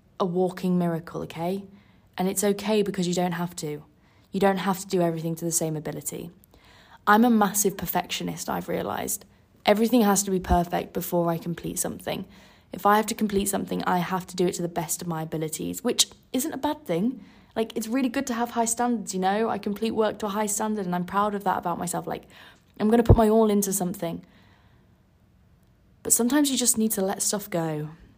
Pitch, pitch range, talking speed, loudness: 195 Hz, 175-220 Hz, 215 wpm, -25 LUFS